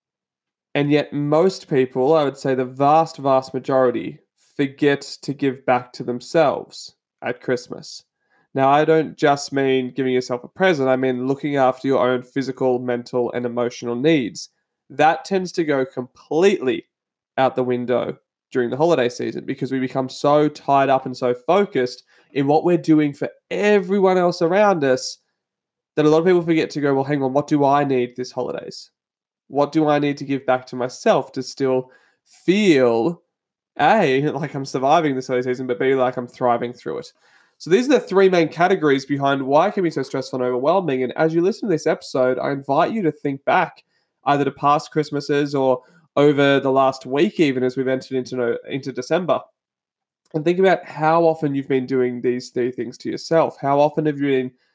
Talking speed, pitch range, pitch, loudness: 190 wpm, 130-155 Hz, 140 Hz, -20 LUFS